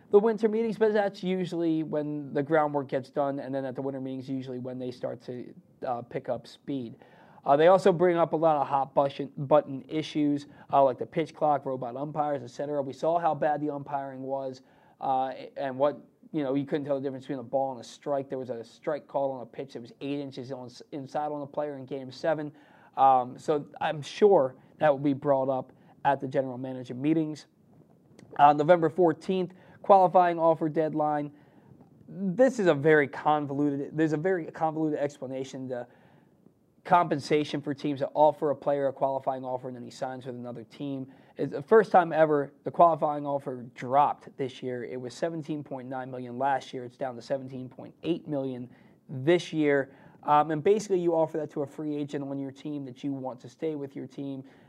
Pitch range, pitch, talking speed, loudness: 135-160 Hz, 145 Hz, 200 wpm, -28 LUFS